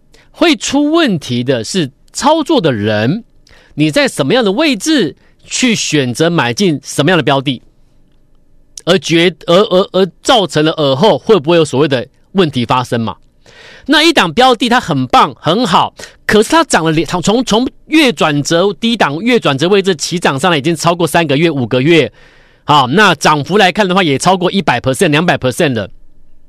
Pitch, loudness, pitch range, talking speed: 170 Hz, -11 LUFS, 145-215 Hz, 280 characters per minute